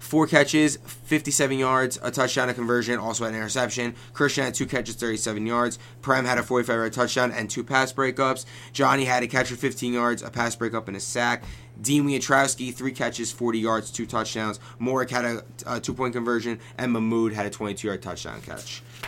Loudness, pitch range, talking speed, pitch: -25 LUFS, 115-130 Hz, 190 wpm, 120 Hz